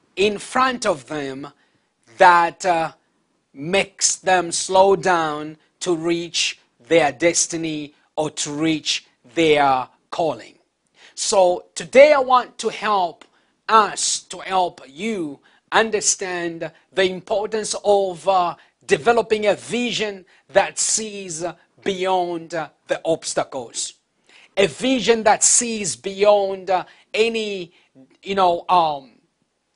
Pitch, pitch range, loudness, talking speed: 185 Hz, 165-205 Hz, -19 LUFS, 105 wpm